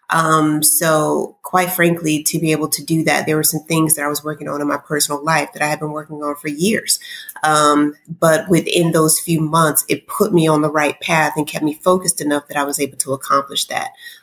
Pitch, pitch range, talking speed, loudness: 155 Hz, 150-165 Hz, 235 wpm, -16 LUFS